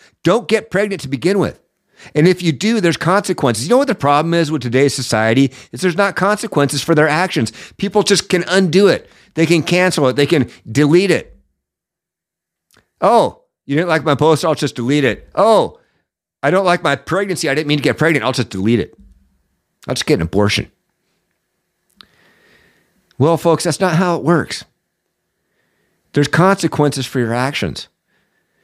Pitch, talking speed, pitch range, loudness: 160 Hz, 175 wpm, 135-185 Hz, -15 LUFS